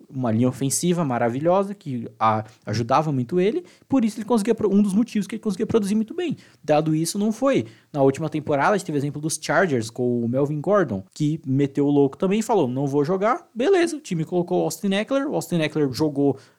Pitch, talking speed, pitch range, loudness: 155 Hz, 215 wpm, 135-205 Hz, -22 LUFS